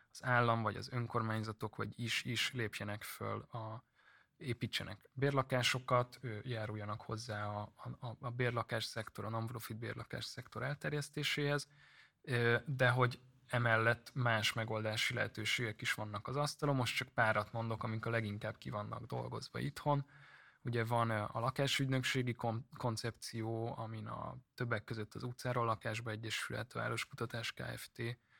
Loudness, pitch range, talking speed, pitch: -38 LUFS, 110-125 Hz, 130 wpm, 115 Hz